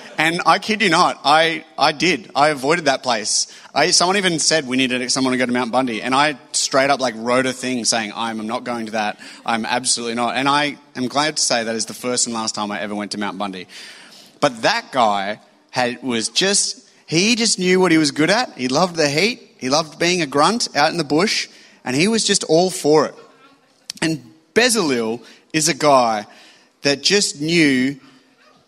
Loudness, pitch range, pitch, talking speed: -18 LUFS, 125-170 Hz, 140 Hz, 215 wpm